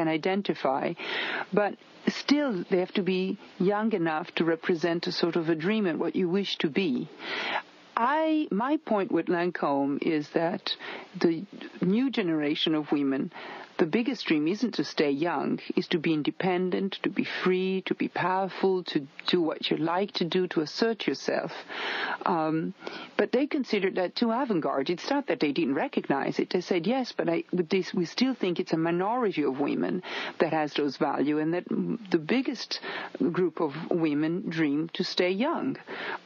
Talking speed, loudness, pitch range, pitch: 175 wpm, -28 LUFS, 165-210 Hz, 180 Hz